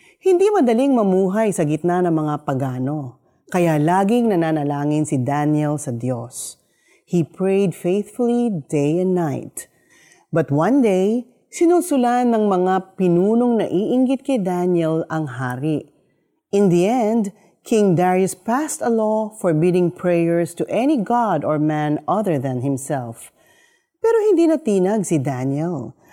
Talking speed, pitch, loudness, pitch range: 130 wpm, 180 Hz, -19 LUFS, 155-230 Hz